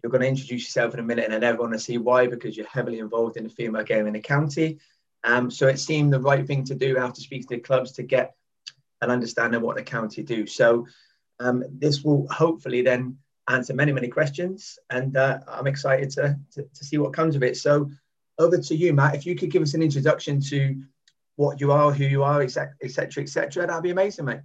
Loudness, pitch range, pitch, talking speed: -24 LUFS, 125-145 Hz, 135 Hz, 245 wpm